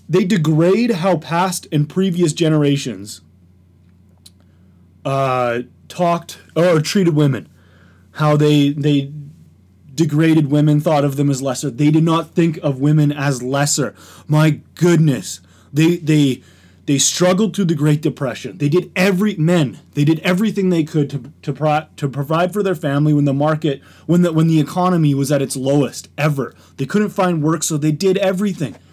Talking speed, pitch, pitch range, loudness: 160 wpm, 150 Hz, 135-170 Hz, -17 LUFS